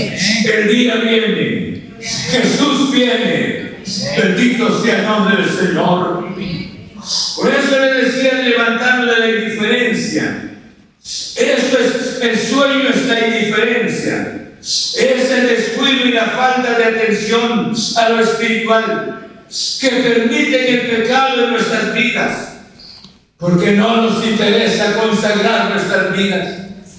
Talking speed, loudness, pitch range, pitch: 110 wpm, -14 LUFS, 215-245 Hz, 225 Hz